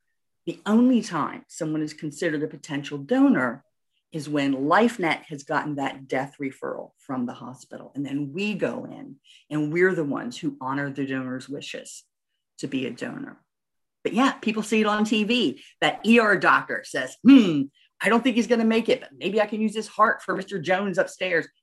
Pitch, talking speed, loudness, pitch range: 185 Hz, 190 wpm, -24 LUFS, 145-225 Hz